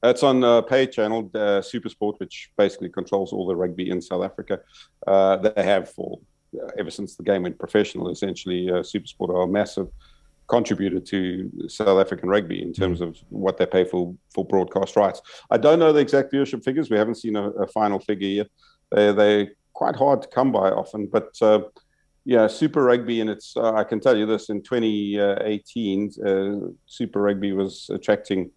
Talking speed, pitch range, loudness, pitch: 195 wpm, 95-110 Hz, -22 LUFS, 105 Hz